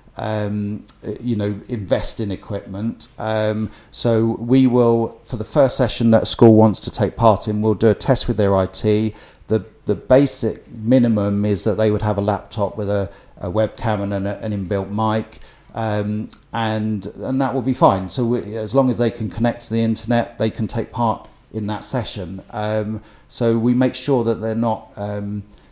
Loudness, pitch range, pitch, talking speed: -19 LUFS, 105-115 Hz, 110 Hz, 195 wpm